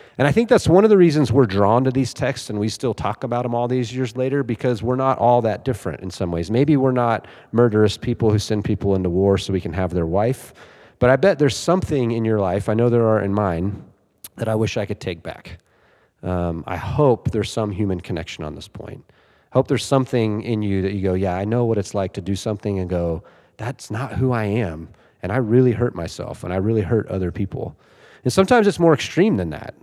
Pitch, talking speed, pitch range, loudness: 110 Hz, 245 wpm, 100-125 Hz, -20 LUFS